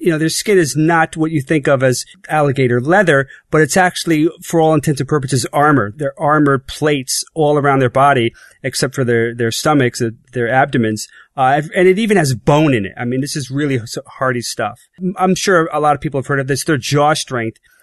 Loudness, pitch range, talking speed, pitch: -15 LUFS, 130-160 Hz, 215 wpm, 145 Hz